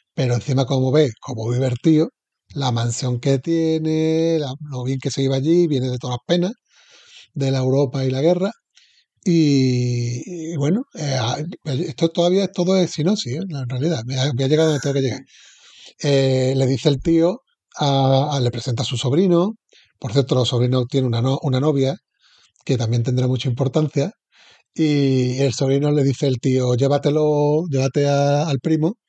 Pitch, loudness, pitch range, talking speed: 140 Hz, -20 LUFS, 130-165 Hz, 180 wpm